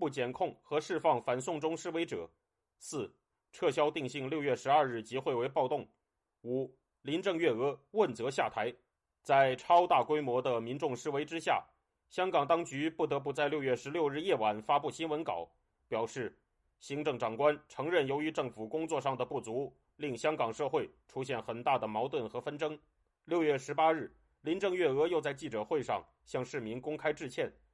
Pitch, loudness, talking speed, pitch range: 145 Hz, -34 LUFS, 265 characters per minute, 125-160 Hz